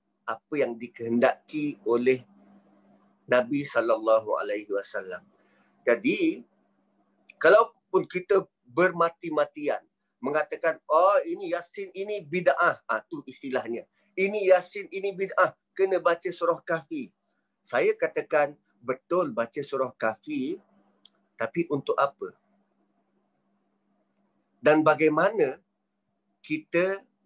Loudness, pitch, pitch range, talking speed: -26 LUFS, 170 Hz, 130-200 Hz, 90 wpm